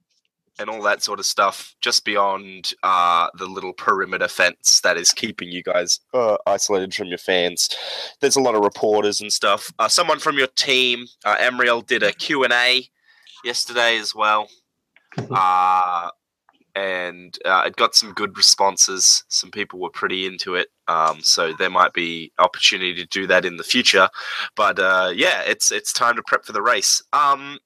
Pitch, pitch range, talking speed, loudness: 105 Hz, 90-125 Hz, 175 wpm, -18 LUFS